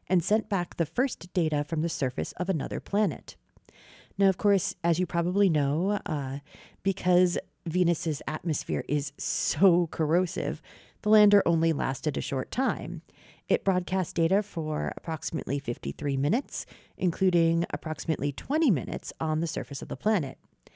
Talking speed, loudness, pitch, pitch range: 145 wpm, -28 LUFS, 170 Hz, 155-195 Hz